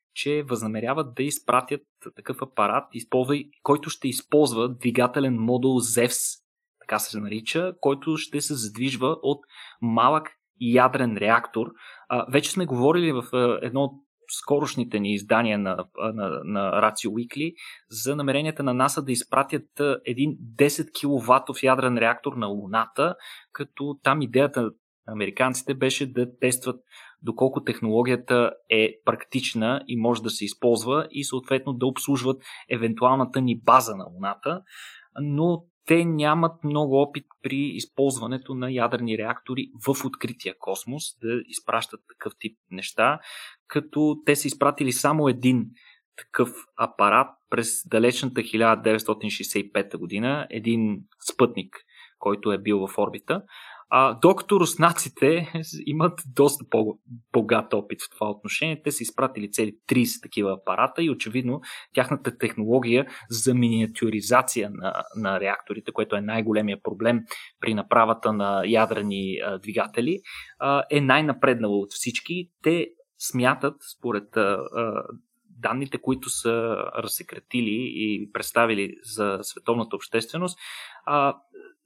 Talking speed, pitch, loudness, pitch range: 120 wpm, 130 Hz, -24 LUFS, 115-145 Hz